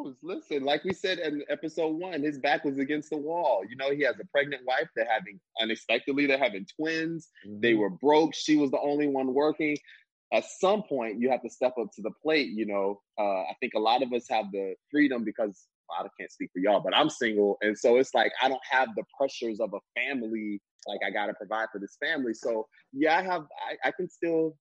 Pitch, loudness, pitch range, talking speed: 140 Hz, -28 LUFS, 110-155 Hz, 235 wpm